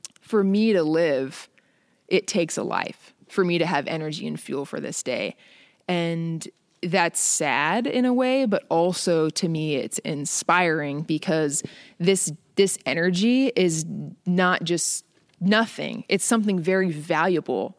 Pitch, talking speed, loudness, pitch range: 180 Hz, 140 wpm, -23 LUFS, 160-195 Hz